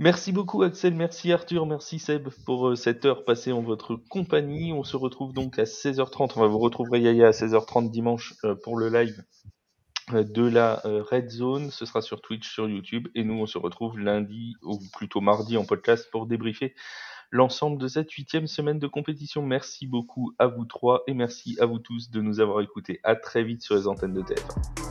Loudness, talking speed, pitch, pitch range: -26 LUFS, 210 wpm, 120 Hz, 110-140 Hz